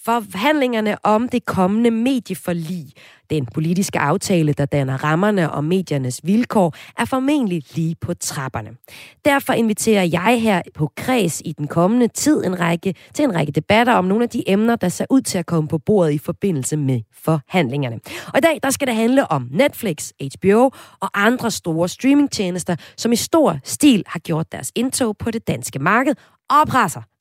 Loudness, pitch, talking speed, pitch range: -18 LUFS, 190 Hz, 175 wpm, 160-235 Hz